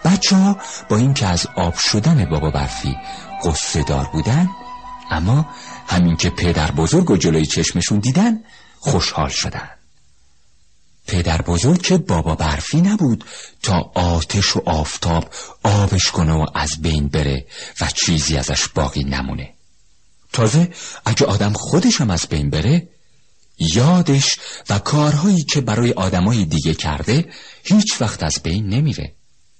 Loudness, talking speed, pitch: -17 LUFS, 130 wpm, 95 Hz